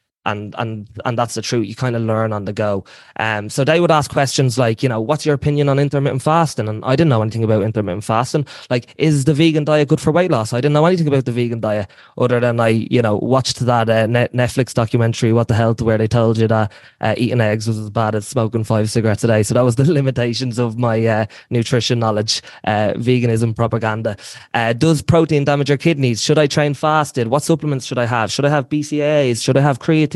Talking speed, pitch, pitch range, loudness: 235 wpm, 120 Hz, 110-145 Hz, -17 LUFS